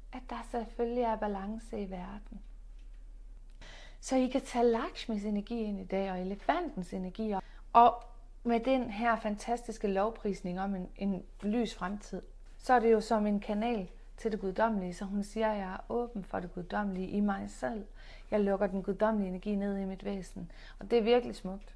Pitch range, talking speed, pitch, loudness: 195-230 Hz, 190 wpm, 210 Hz, -33 LUFS